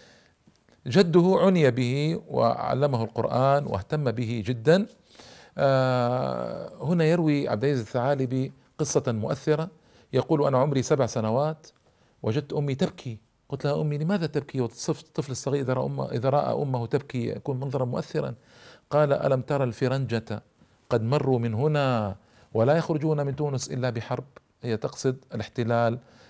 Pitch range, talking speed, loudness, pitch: 120-150 Hz, 130 wpm, -26 LUFS, 135 Hz